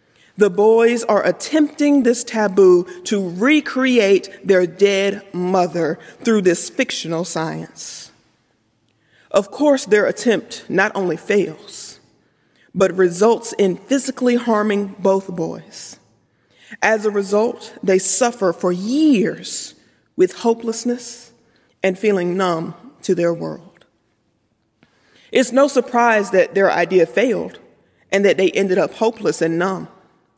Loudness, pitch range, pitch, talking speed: -17 LUFS, 180-235 Hz, 200 Hz, 115 wpm